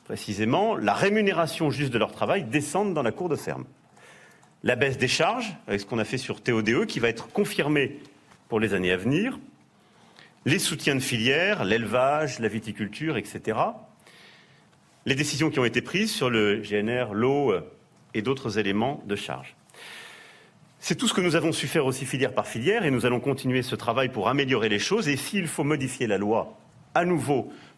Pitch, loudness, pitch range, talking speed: 130 Hz, -25 LUFS, 110-155 Hz, 185 wpm